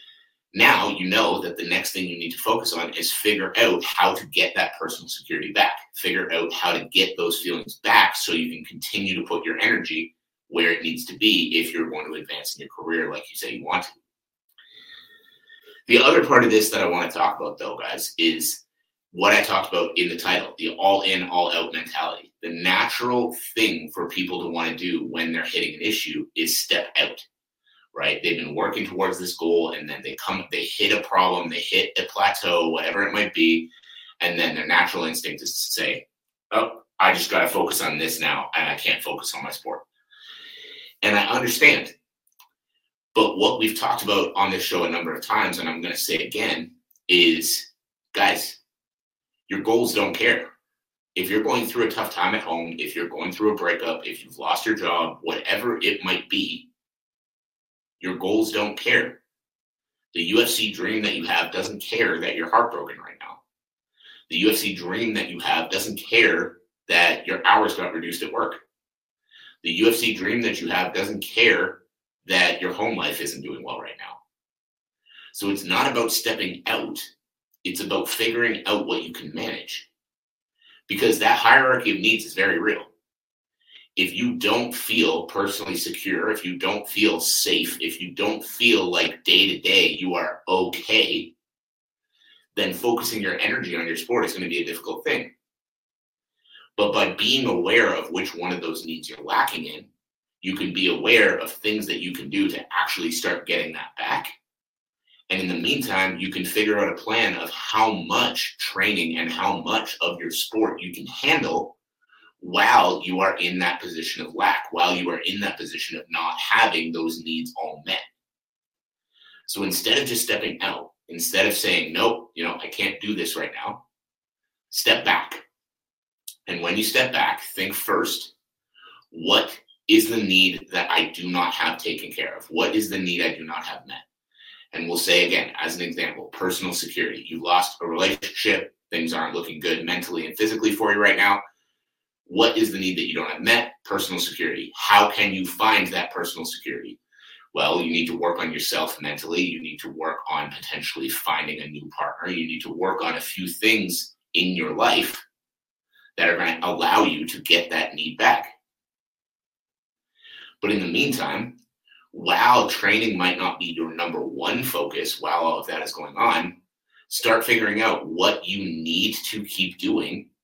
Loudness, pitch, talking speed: -22 LUFS, 110 Hz, 190 wpm